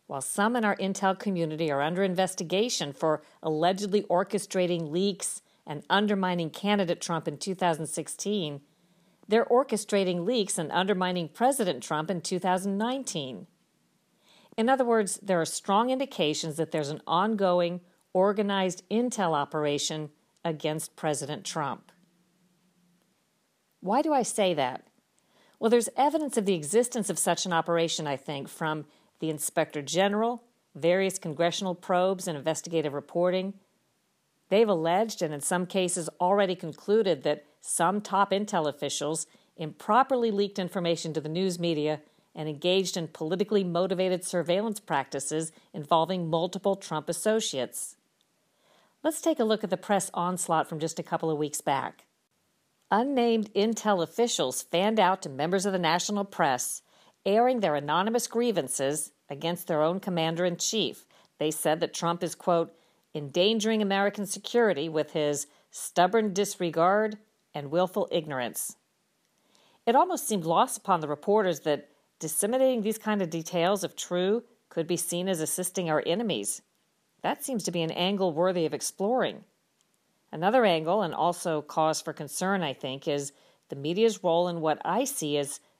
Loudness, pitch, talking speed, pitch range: -28 LUFS, 180 Hz, 145 wpm, 160-205 Hz